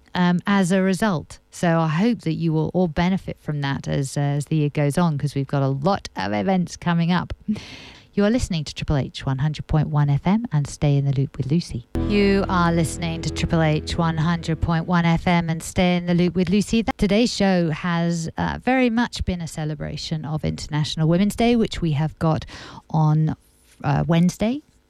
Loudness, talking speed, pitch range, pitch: -22 LUFS, 210 wpm, 150-185 Hz, 165 Hz